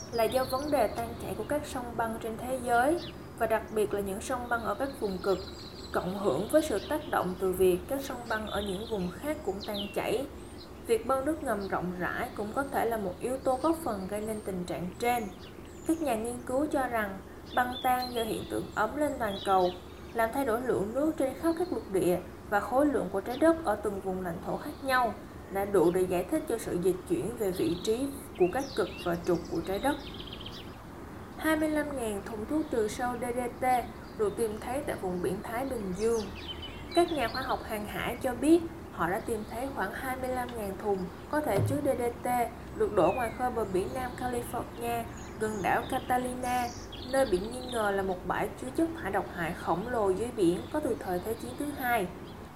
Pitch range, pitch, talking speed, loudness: 200-275 Hz, 240 Hz, 215 wpm, -31 LUFS